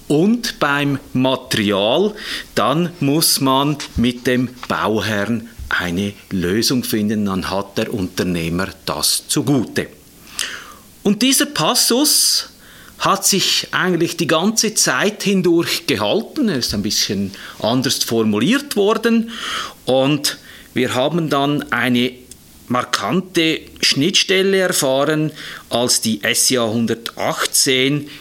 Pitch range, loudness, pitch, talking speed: 115-175 Hz, -17 LUFS, 135 Hz, 100 wpm